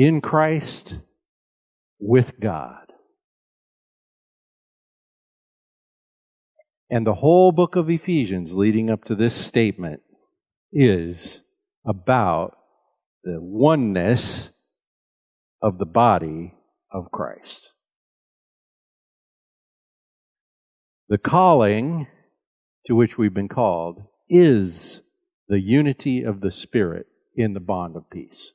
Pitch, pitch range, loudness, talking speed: 115 Hz, 100-155 Hz, -20 LUFS, 90 wpm